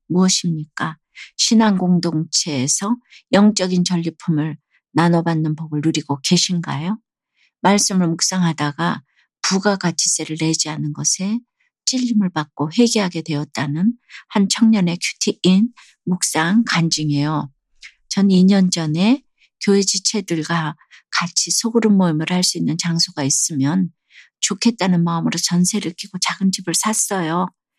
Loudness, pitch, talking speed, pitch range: -18 LUFS, 175 Hz, 275 characters per minute, 160-200 Hz